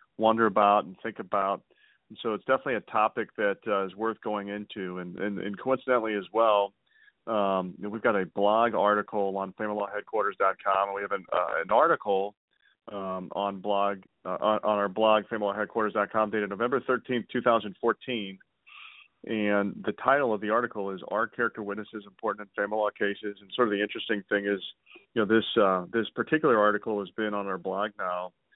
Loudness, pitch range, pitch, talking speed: -28 LUFS, 100-110 Hz, 105 Hz, 180 wpm